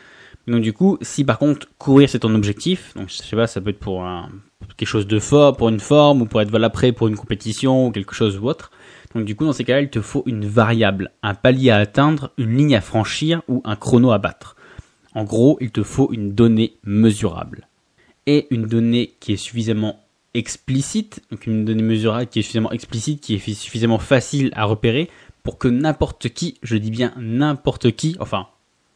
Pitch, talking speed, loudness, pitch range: 115 Hz, 215 wpm, -18 LUFS, 110-135 Hz